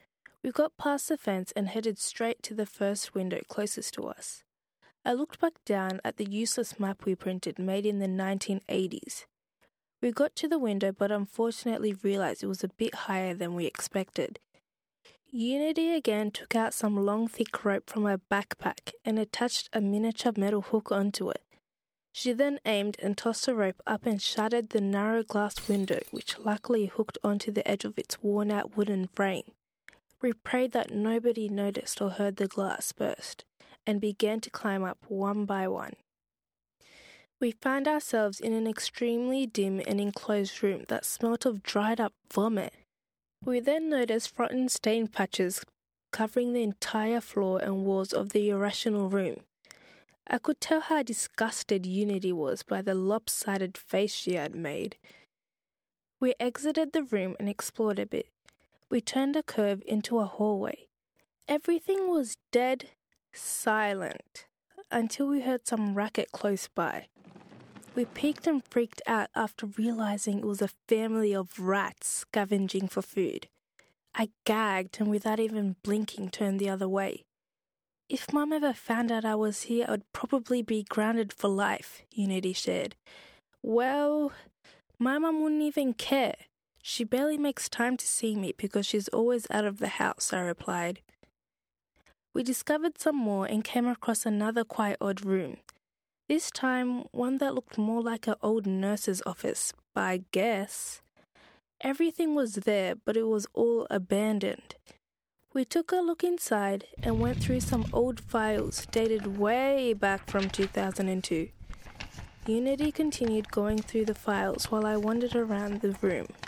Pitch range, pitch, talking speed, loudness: 200-245 Hz, 215 Hz, 155 wpm, -30 LUFS